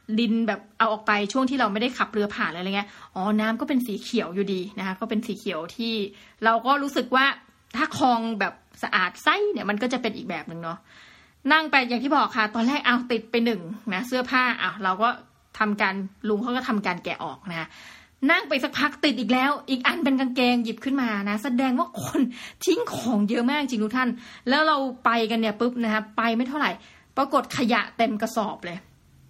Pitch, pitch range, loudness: 230 Hz, 210-260 Hz, -24 LUFS